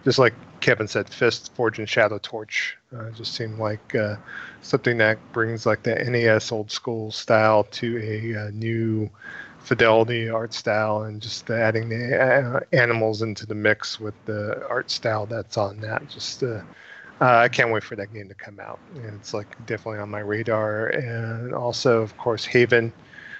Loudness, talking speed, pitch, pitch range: -23 LUFS, 180 wpm, 110 Hz, 110-115 Hz